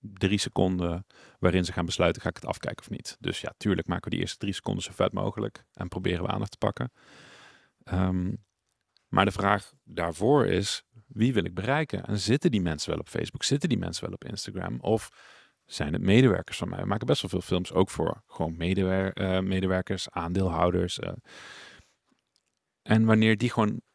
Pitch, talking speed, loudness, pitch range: 95 Hz, 195 wpm, -28 LUFS, 90-105 Hz